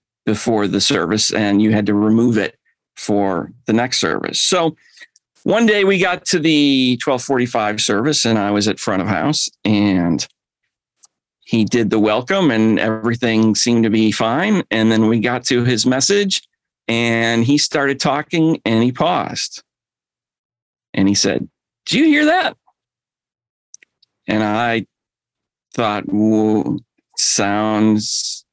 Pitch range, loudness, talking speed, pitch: 105-140 Hz, -16 LUFS, 140 wpm, 115 Hz